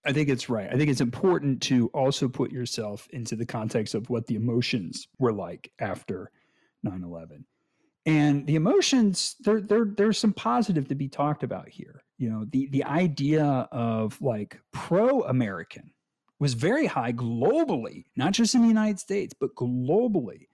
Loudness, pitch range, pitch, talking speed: -26 LUFS, 120-195 Hz, 140 Hz, 165 wpm